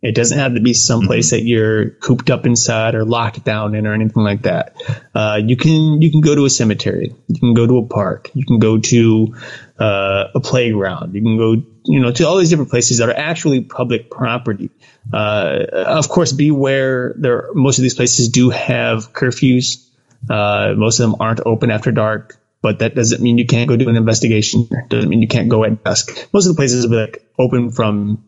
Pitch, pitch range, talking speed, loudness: 120 Hz, 110-130 Hz, 220 wpm, -14 LUFS